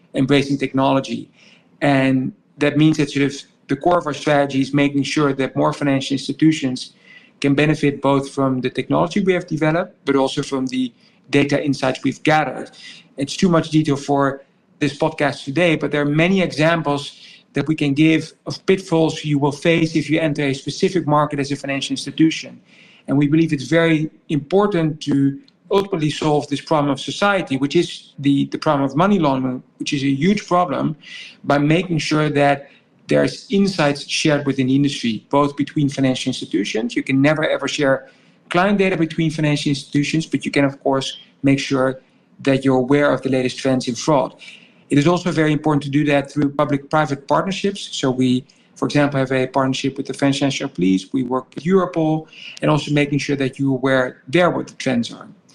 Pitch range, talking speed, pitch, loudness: 135-160 Hz, 190 wpm, 145 Hz, -19 LUFS